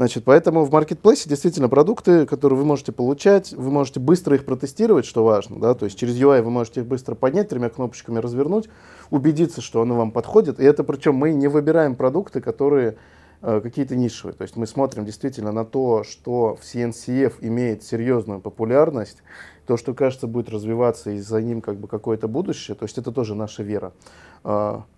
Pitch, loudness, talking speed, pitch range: 125 Hz, -20 LUFS, 185 wpm, 115-145 Hz